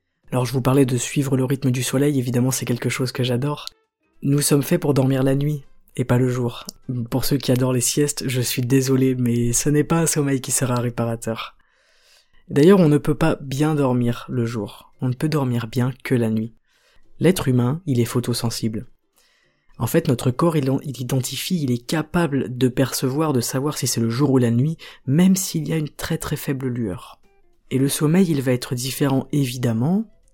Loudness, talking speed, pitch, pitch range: -21 LUFS, 210 wpm, 130 Hz, 125-150 Hz